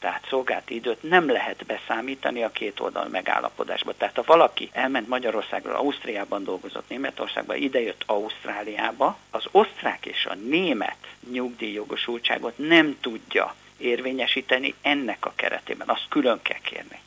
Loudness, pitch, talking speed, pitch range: -25 LUFS, 125 Hz, 125 wpm, 120-135 Hz